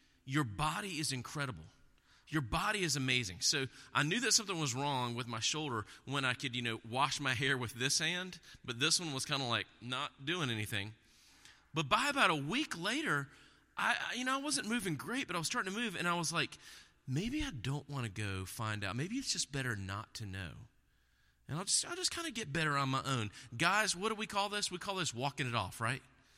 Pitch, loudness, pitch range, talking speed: 140 Hz, -35 LUFS, 125-175 Hz, 230 wpm